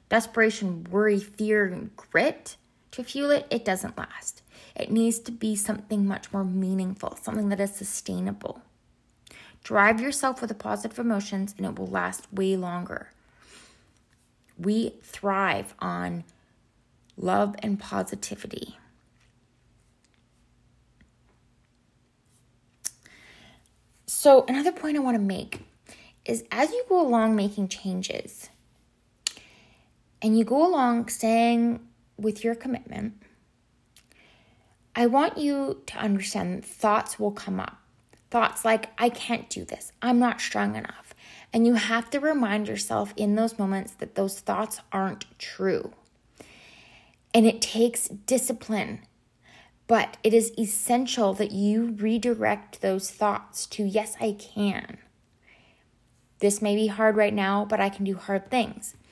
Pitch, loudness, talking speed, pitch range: 210 Hz, -26 LUFS, 125 wpm, 190-230 Hz